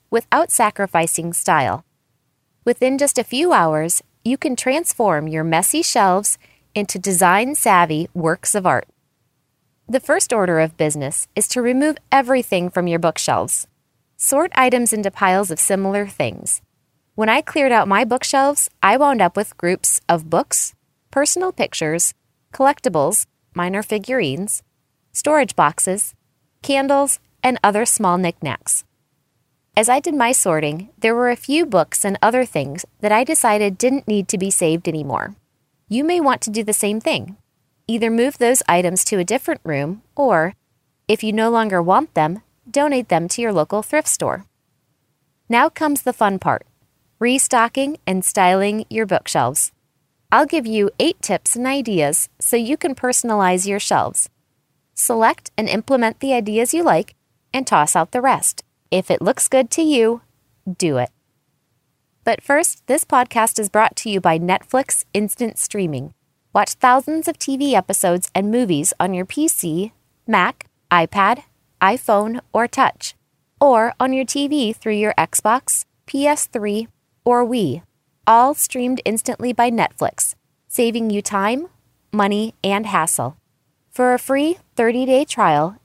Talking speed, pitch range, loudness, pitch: 150 wpm, 175-255 Hz, -18 LUFS, 215 Hz